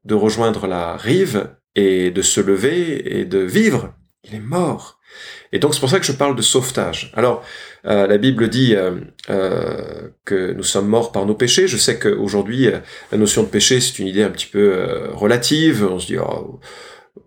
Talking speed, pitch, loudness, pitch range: 200 wpm, 110 Hz, -17 LUFS, 100-130 Hz